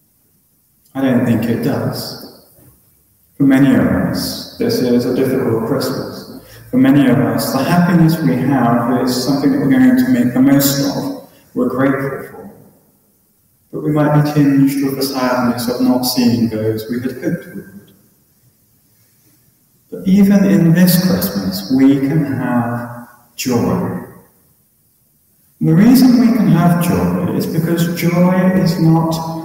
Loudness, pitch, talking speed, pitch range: -14 LUFS, 140 Hz, 145 wpm, 125-180 Hz